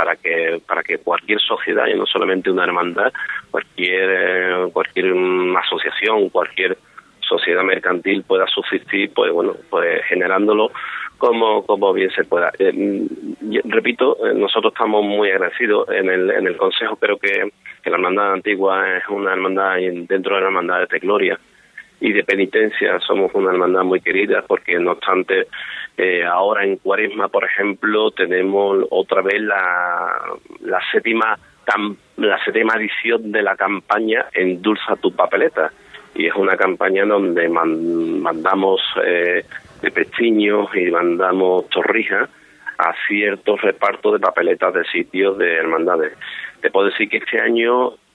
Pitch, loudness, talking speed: 110 Hz, -17 LUFS, 145 wpm